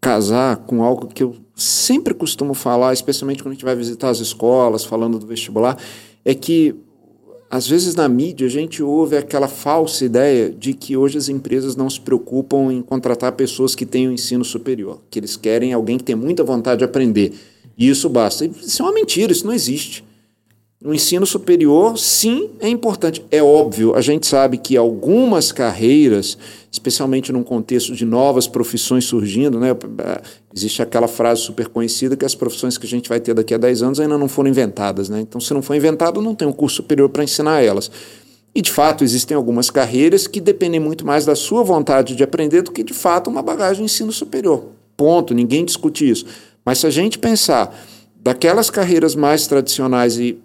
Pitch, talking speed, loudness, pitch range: 130 Hz, 195 wpm, -16 LUFS, 120-155 Hz